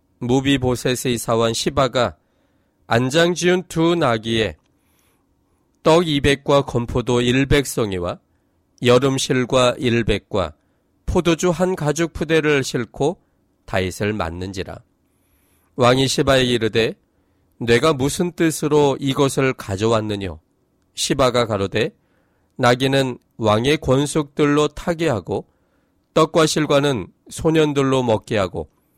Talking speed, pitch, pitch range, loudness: 215 characters per minute, 125 Hz, 105-145 Hz, -19 LUFS